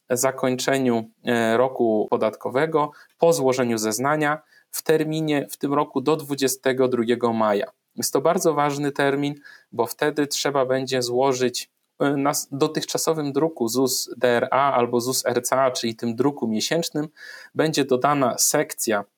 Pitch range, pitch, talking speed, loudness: 120-150 Hz, 135 Hz, 115 wpm, -22 LUFS